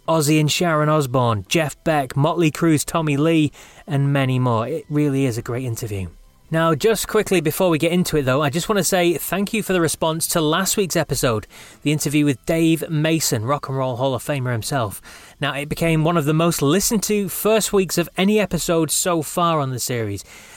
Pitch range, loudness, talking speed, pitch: 135-170 Hz, -19 LUFS, 215 wpm, 155 Hz